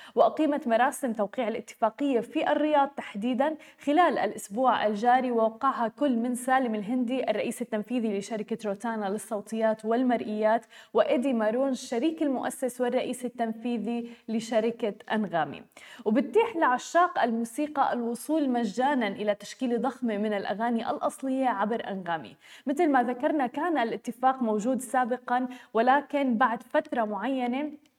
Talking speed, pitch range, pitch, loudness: 115 wpm, 225-270 Hz, 245 Hz, -28 LUFS